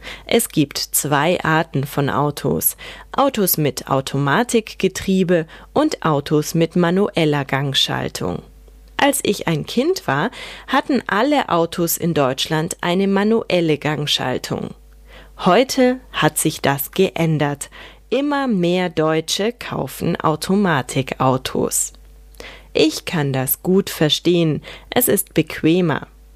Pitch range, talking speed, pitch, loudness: 145-195 Hz, 100 wpm, 165 Hz, -18 LUFS